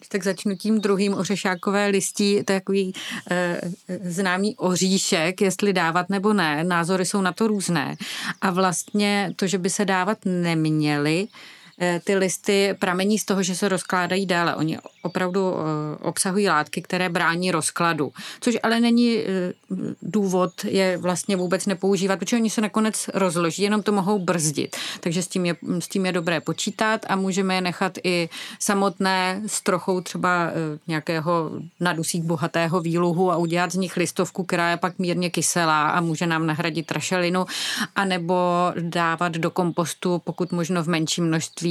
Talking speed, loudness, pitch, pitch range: 155 wpm, -23 LUFS, 185 Hz, 170-200 Hz